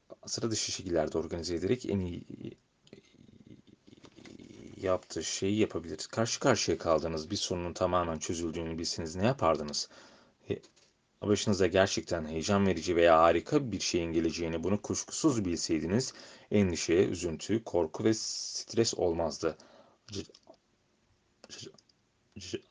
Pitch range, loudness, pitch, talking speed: 85-105 Hz, -31 LUFS, 90 Hz, 110 wpm